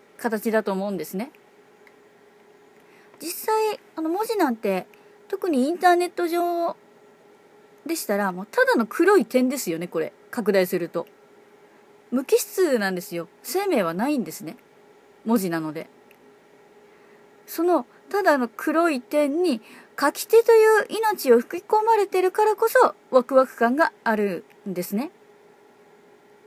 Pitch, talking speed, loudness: 295 Hz, 255 characters per minute, -22 LUFS